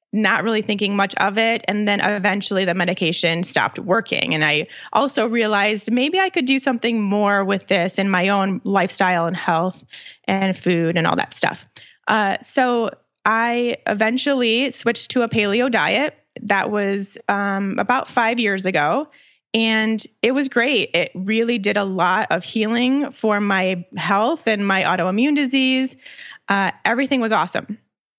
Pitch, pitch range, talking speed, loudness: 210 Hz, 190-235 Hz, 160 wpm, -19 LUFS